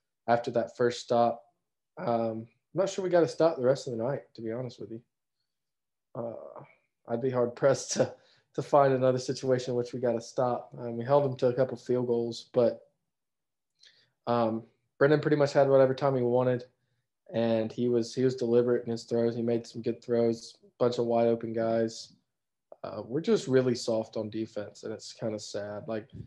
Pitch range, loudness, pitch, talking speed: 115-130 Hz, -29 LUFS, 120 Hz, 205 wpm